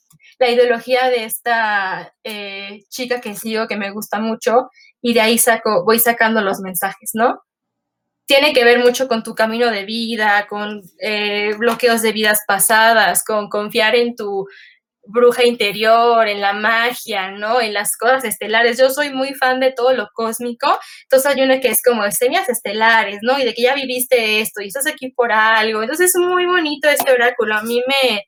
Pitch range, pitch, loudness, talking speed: 215-250 Hz, 230 Hz, -15 LUFS, 185 wpm